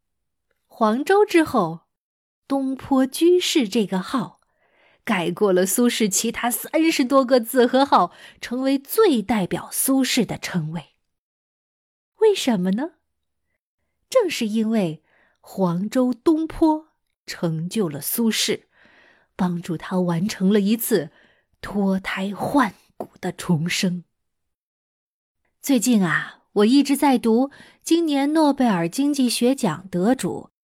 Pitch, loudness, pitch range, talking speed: 235 Hz, -21 LUFS, 190-275 Hz, 170 characters per minute